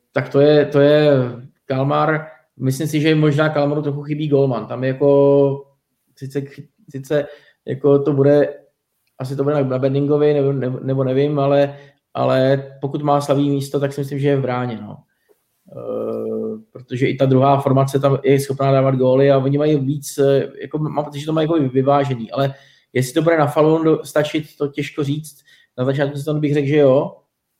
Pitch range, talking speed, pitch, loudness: 135-145 Hz, 180 wpm, 140 Hz, -17 LUFS